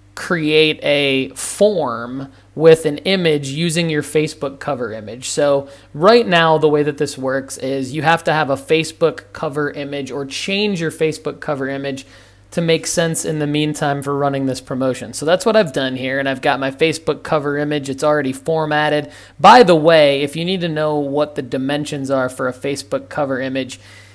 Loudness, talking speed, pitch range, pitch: -17 LUFS, 190 wpm, 135-160 Hz, 145 Hz